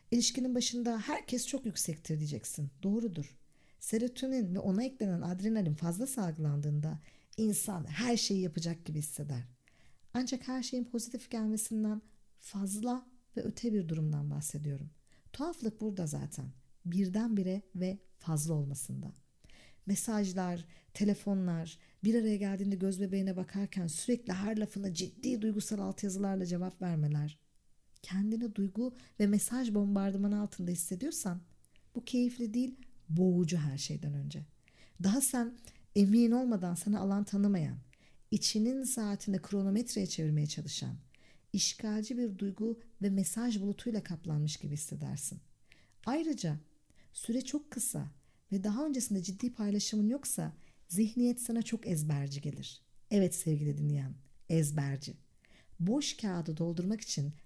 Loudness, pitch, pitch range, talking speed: -34 LUFS, 195 Hz, 155-225 Hz, 115 wpm